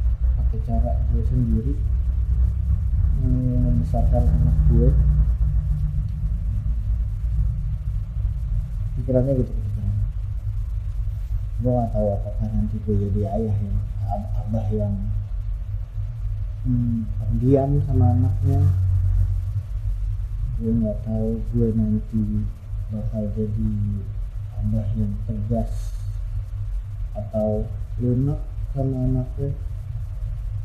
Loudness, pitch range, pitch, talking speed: -24 LUFS, 95-110 Hz, 105 Hz, 75 wpm